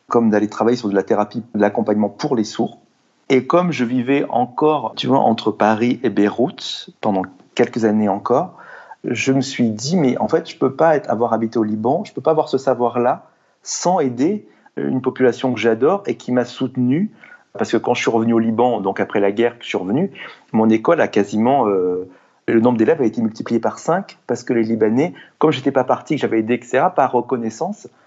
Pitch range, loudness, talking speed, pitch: 110-130 Hz, -18 LUFS, 220 wpm, 120 Hz